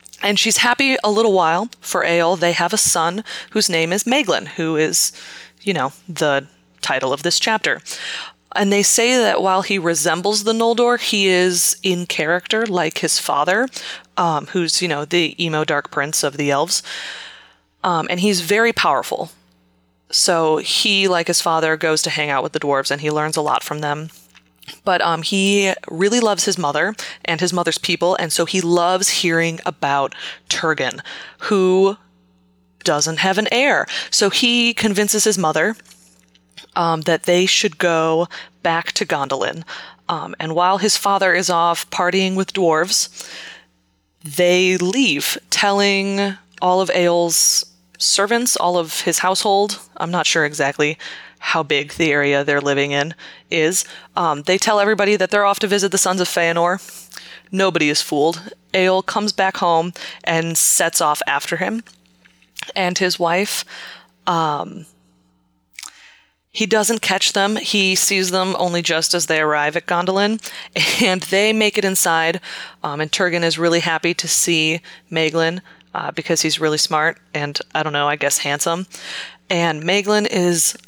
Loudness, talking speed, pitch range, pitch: -17 LUFS, 160 wpm, 160-195 Hz, 175 Hz